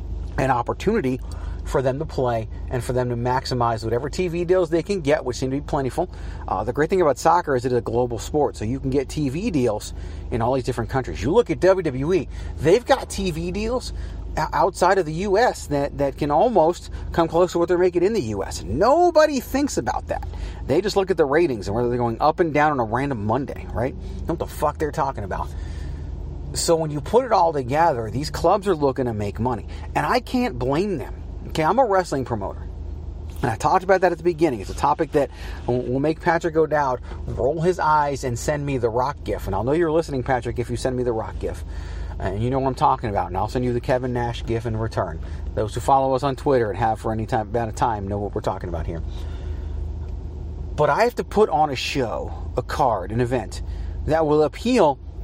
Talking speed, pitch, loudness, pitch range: 230 wpm, 125 Hz, -22 LUFS, 95-155 Hz